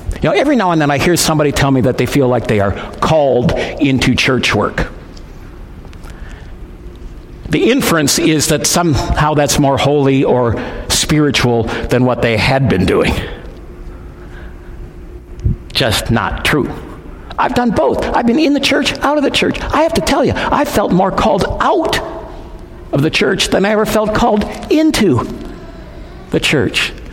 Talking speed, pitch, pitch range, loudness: 160 wpm, 135 Hz, 105-175 Hz, -13 LUFS